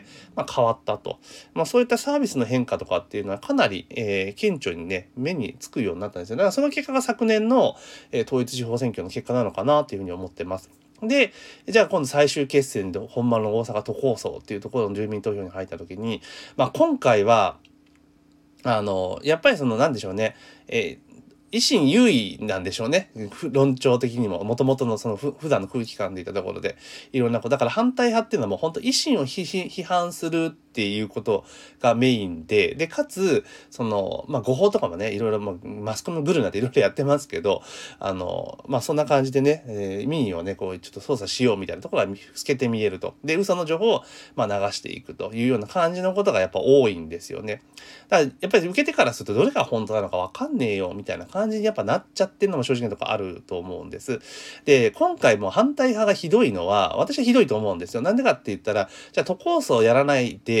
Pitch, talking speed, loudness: 140 Hz, 445 characters per minute, -23 LUFS